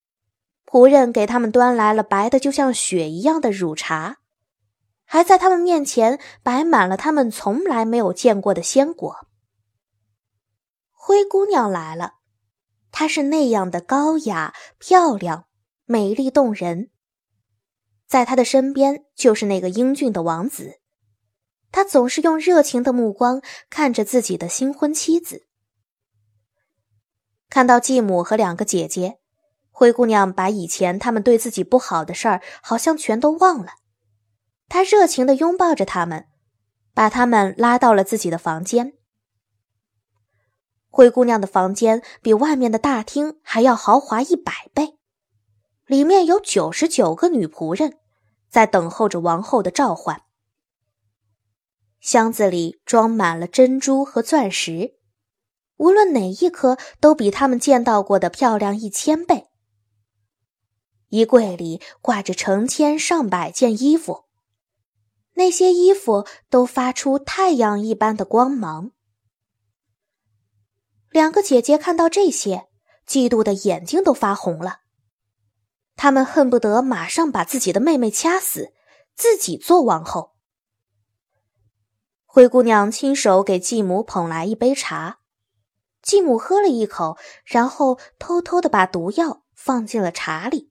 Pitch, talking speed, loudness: 215 Hz, 200 characters per minute, -18 LUFS